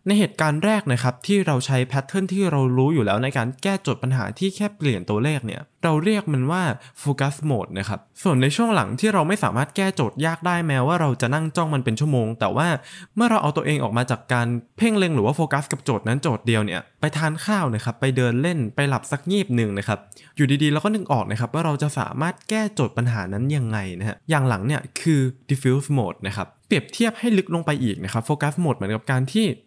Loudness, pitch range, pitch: -22 LUFS, 120-165 Hz, 140 Hz